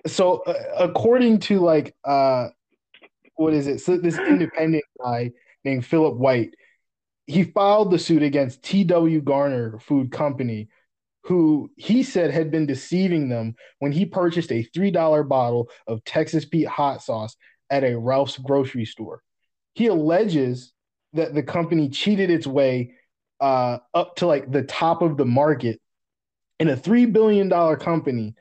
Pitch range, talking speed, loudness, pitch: 130-175 Hz, 145 wpm, -21 LUFS, 150 Hz